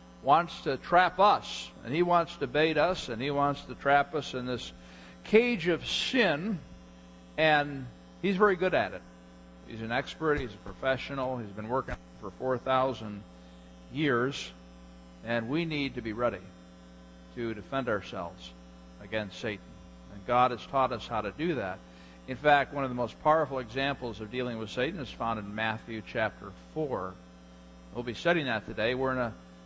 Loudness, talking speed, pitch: -30 LUFS, 170 wpm, 115 Hz